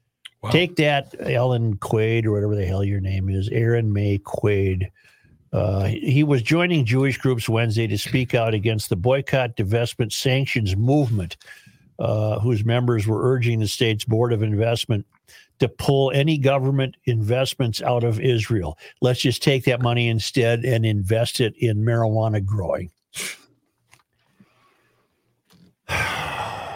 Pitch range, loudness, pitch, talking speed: 110-130 Hz, -21 LUFS, 115 Hz, 135 wpm